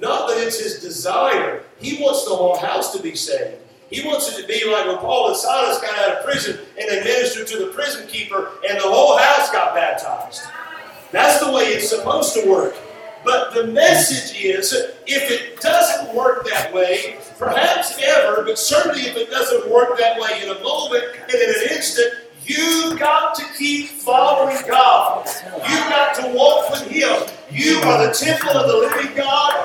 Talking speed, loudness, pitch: 190 wpm, -17 LUFS, 290 Hz